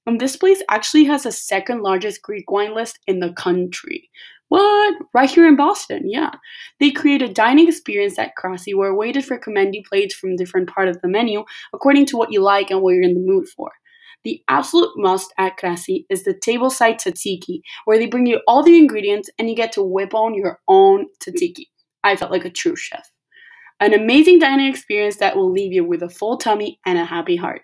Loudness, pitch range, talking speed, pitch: -17 LUFS, 195-320 Hz, 215 wpm, 225 Hz